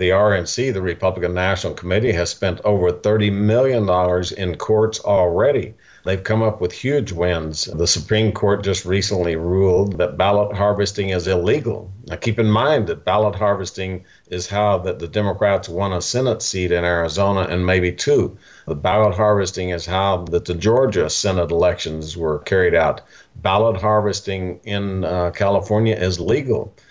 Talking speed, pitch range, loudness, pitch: 160 wpm, 90-105 Hz, -19 LUFS, 95 Hz